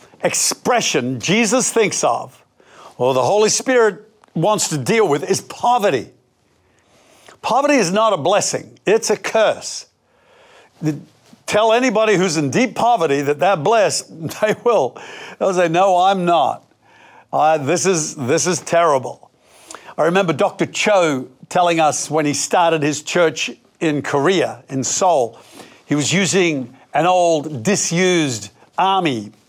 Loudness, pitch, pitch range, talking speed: -17 LUFS, 180 Hz, 155-215 Hz, 135 wpm